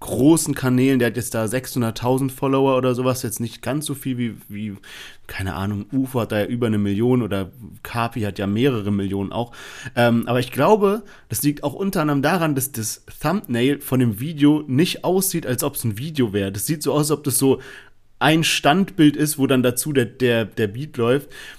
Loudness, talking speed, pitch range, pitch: -20 LUFS, 210 wpm, 115-145 Hz, 125 Hz